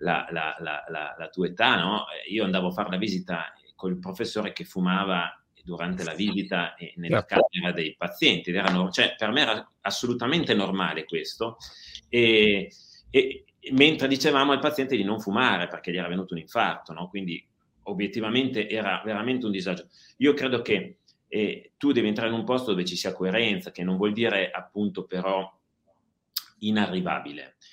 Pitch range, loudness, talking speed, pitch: 90-115 Hz, -26 LUFS, 165 wpm, 100 Hz